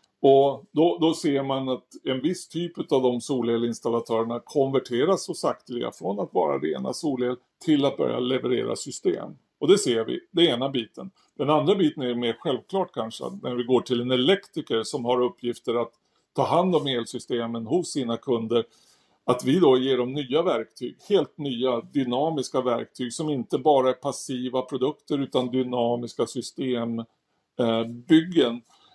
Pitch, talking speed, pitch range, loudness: 130 Hz, 160 wpm, 120-140 Hz, -25 LUFS